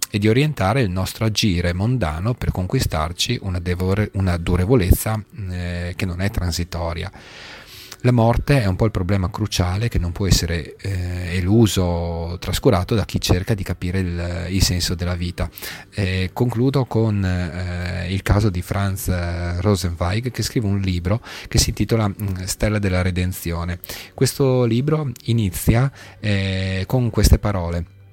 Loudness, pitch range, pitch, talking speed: -21 LUFS, 90-110 Hz, 95 Hz, 150 wpm